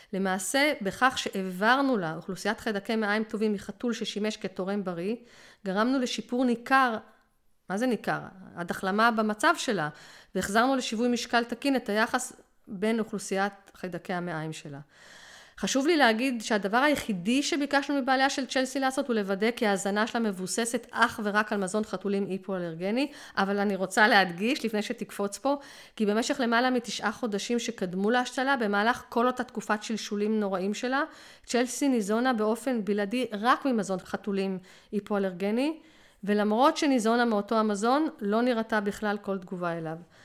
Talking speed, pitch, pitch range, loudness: 140 wpm, 220 Hz, 200-250 Hz, -28 LUFS